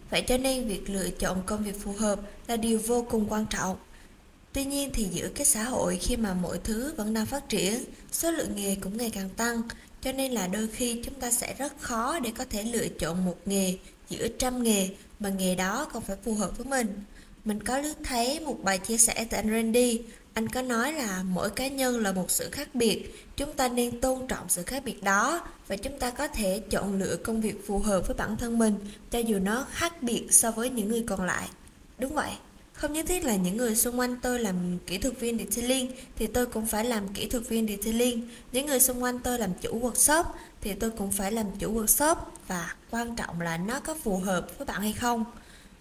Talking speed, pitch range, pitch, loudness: 230 wpm, 200-250 Hz, 225 Hz, -28 LUFS